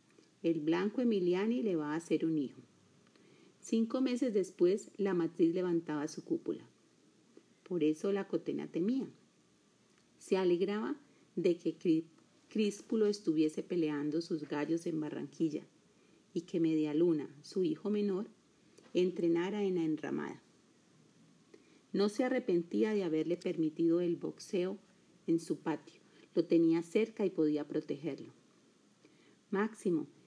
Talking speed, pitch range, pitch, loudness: 120 wpm, 160-205 Hz, 175 Hz, -35 LUFS